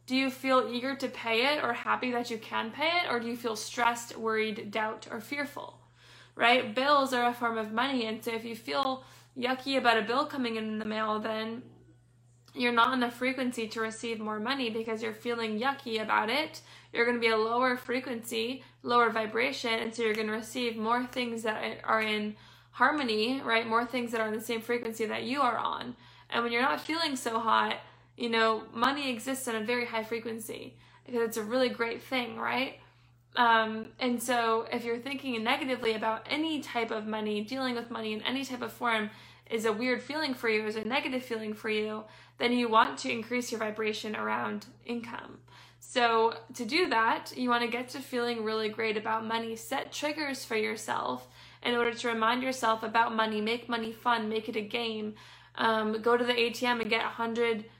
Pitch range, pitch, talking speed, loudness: 225-250 Hz, 235 Hz, 205 wpm, -30 LUFS